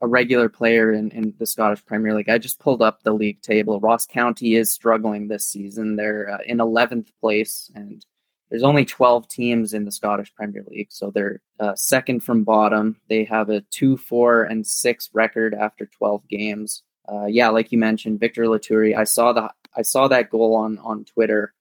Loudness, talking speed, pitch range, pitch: -20 LUFS, 195 wpm, 105-115 Hz, 110 Hz